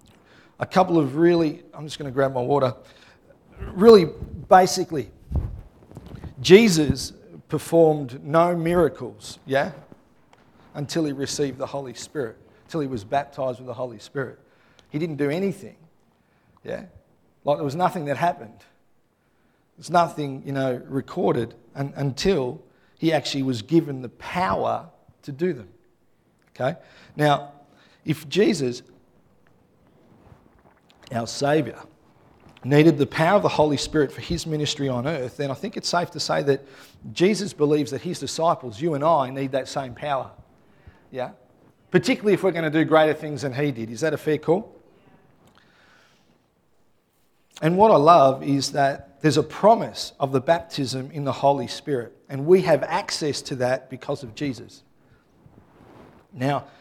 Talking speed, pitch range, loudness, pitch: 150 wpm, 135-165 Hz, -22 LUFS, 145 Hz